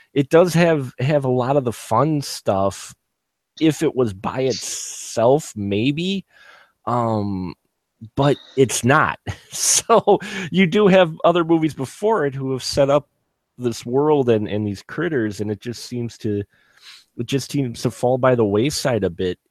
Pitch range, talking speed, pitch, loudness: 110-150 Hz, 165 wpm, 130 Hz, -19 LUFS